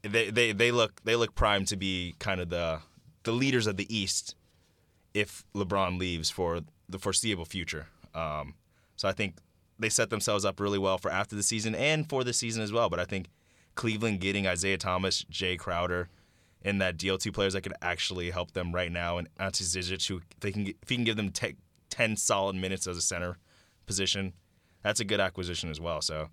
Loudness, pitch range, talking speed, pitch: -30 LUFS, 90-105 Hz, 205 wpm, 95 Hz